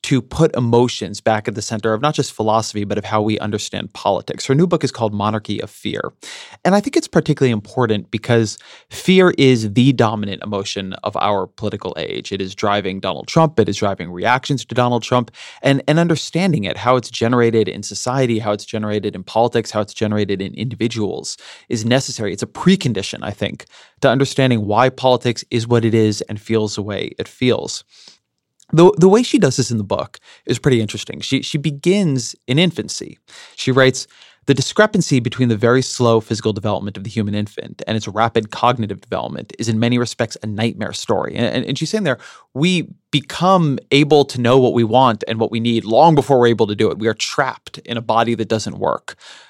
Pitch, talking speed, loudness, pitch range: 120 Hz, 205 wpm, -17 LUFS, 110-135 Hz